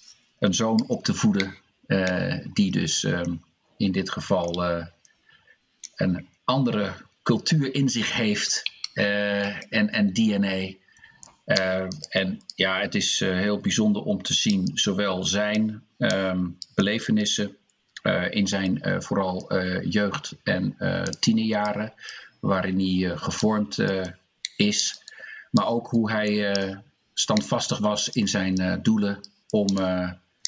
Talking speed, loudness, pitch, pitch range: 130 wpm, -25 LUFS, 100 Hz, 95-110 Hz